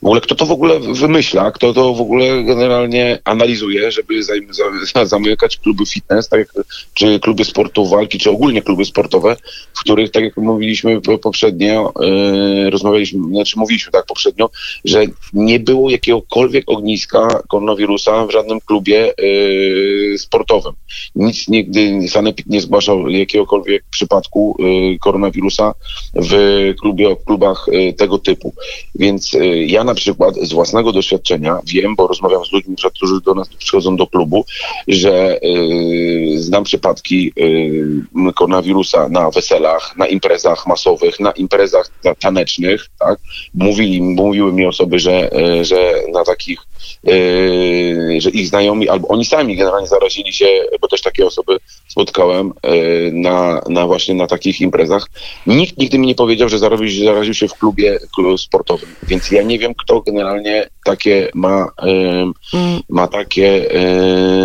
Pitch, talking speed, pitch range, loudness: 105 Hz, 135 wpm, 95-125 Hz, -13 LUFS